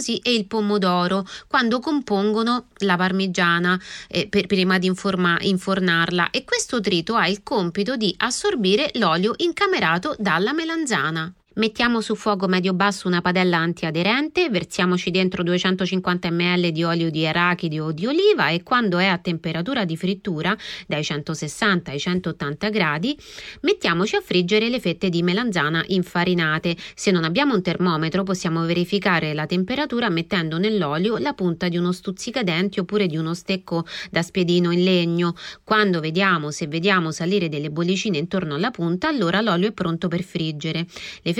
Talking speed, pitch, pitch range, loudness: 150 wpm, 185 Hz, 170-210 Hz, -21 LUFS